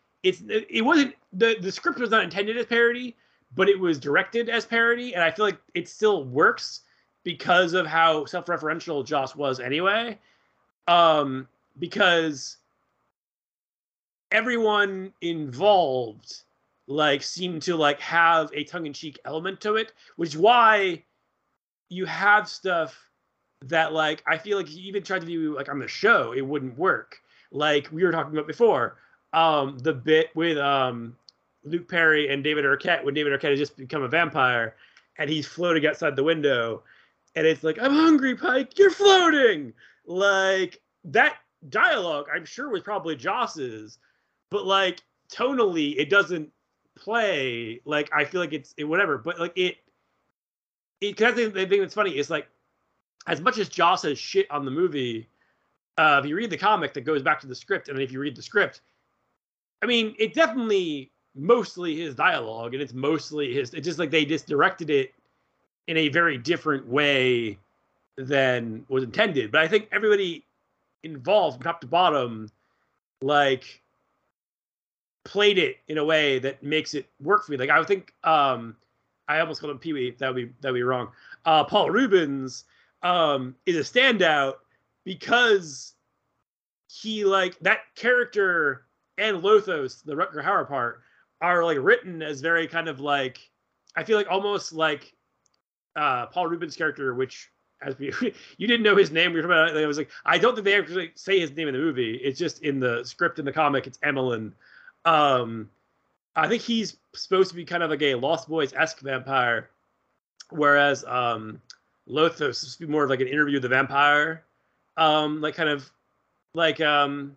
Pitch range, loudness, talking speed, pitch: 145-200 Hz, -23 LUFS, 170 wpm, 160 Hz